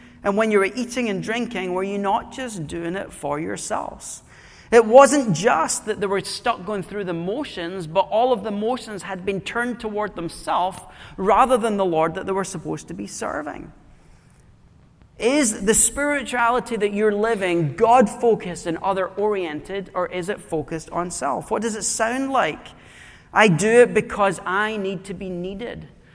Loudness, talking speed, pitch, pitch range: -21 LUFS, 180 wpm, 205 Hz, 185-235 Hz